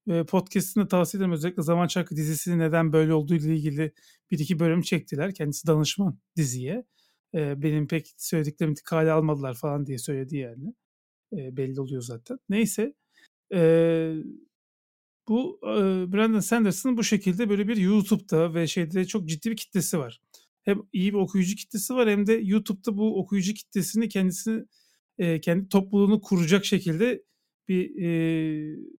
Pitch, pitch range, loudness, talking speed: 185 Hz, 160-210 Hz, -26 LUFS, 135 wpm